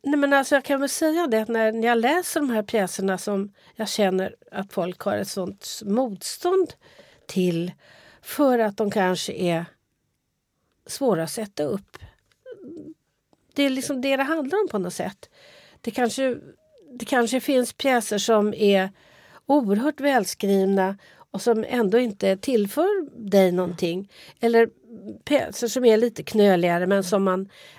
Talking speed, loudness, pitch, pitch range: 150 wpm, -23 LUFS, 225 Hz, 195-270 Hz